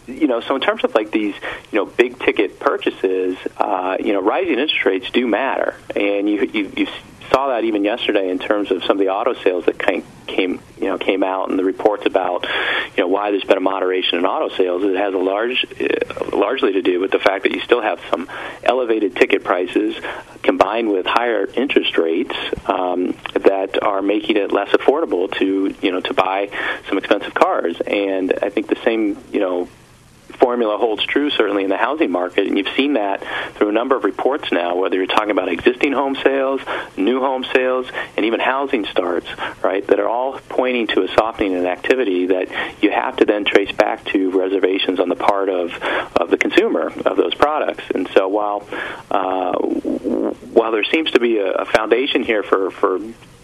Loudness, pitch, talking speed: -18 LUFS, 130 Hz, 200 wpm